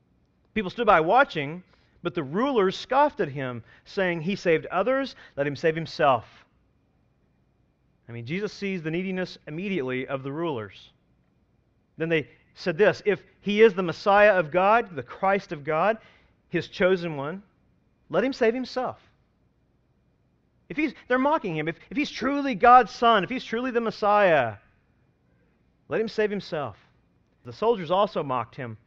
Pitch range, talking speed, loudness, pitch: 155-225 Hz, 155 wpm, -25 LUFS, 185 Hz